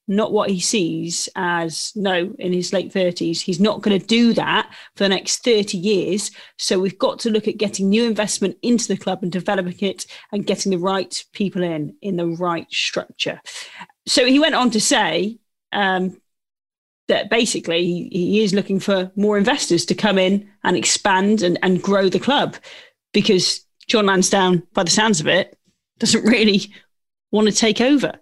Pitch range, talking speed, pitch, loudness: 185-215 Hz, 180 wpm, 200 Hz, -19 LUFS